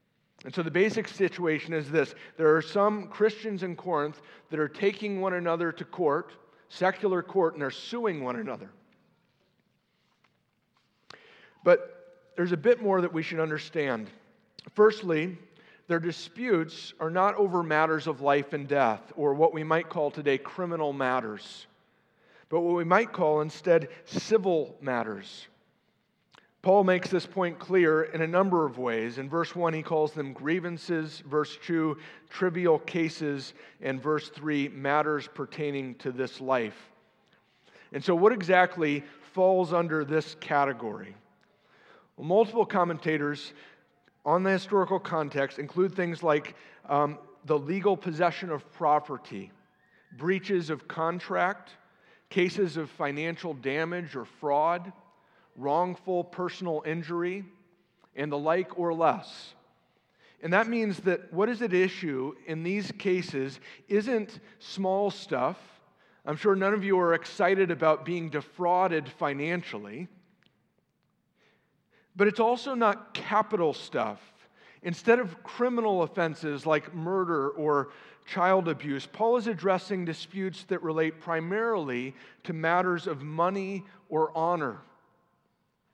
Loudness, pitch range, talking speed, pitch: -28 LUFS, 150-190 Hz, 130 wpm, 170 Hz